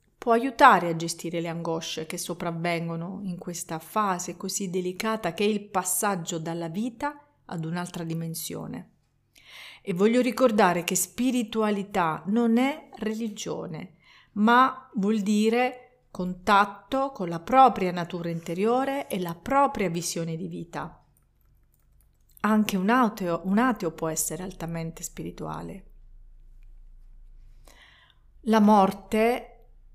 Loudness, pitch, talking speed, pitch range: -26 LUFS, 185 Hz, 110 wpm, 165-225 Hz